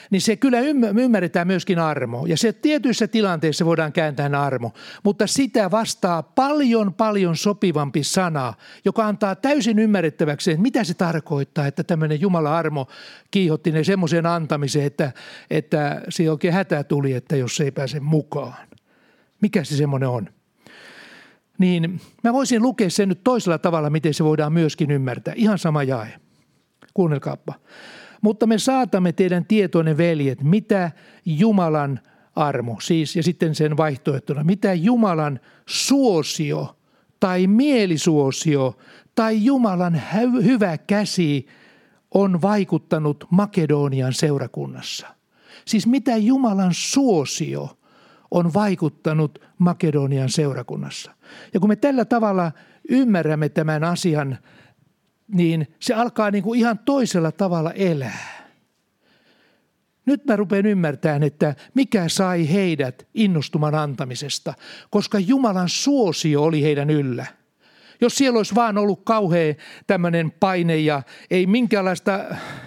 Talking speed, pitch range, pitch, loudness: 125 wpm, 155-215 Hz, 175 Hz, -20 LUFS